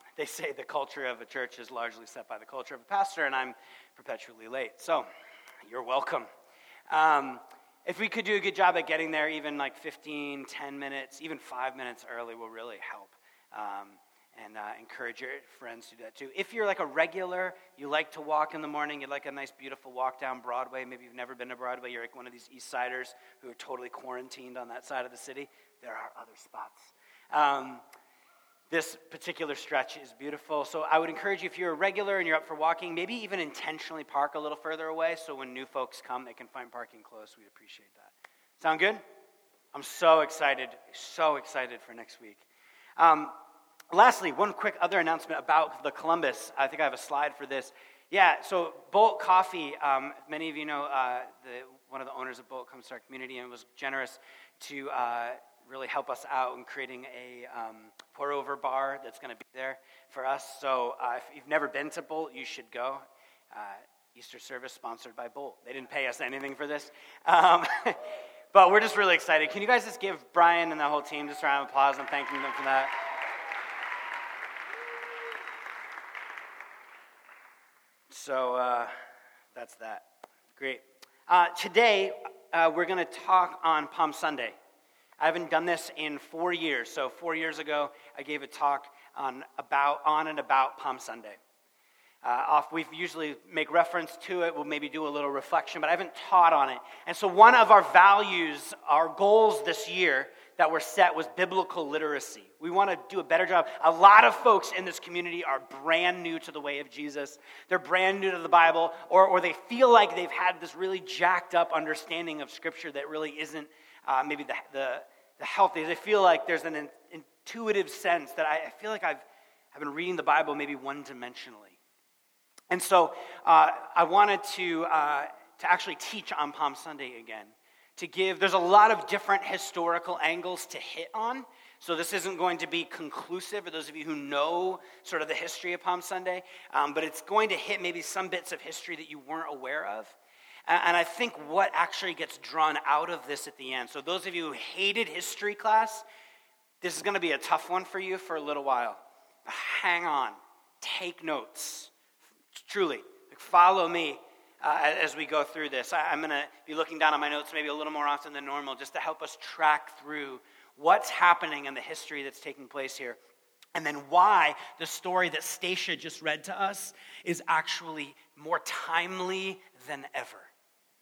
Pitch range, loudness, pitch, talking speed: 140-180 Hz, -28 LUFS, 160 Hz, 200 wpm